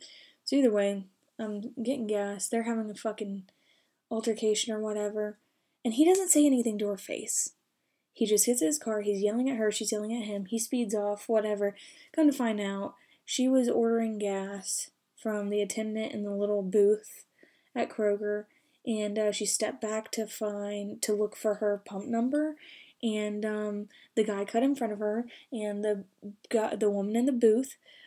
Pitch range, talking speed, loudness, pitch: 210-235 Hz, 180 wpm, -30 LUFS, 215 Hz